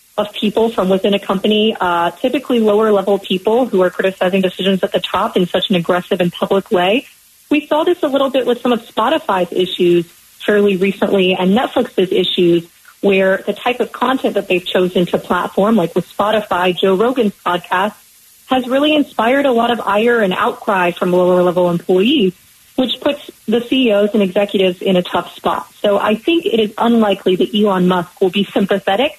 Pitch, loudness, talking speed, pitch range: 200 Hz, -15 LUFS, 190 wpm, 185-230 Hz